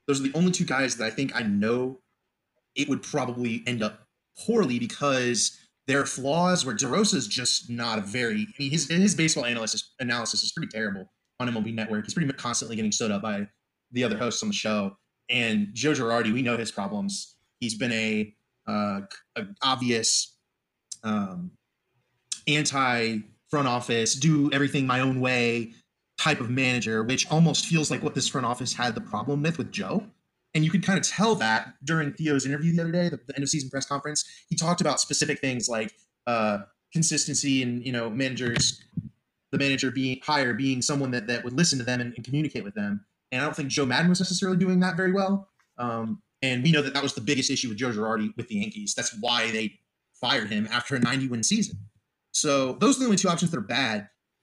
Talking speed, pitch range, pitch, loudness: 210 wpm, 120-165 Hz, 135 Hz, -26 LUFS